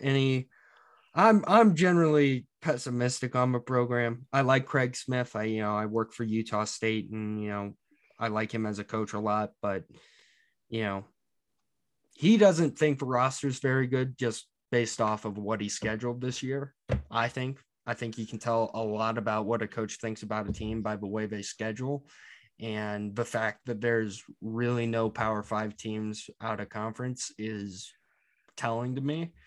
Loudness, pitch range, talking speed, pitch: -30 LUFS, 110-130 Hz, 185 wpm, 115 Hz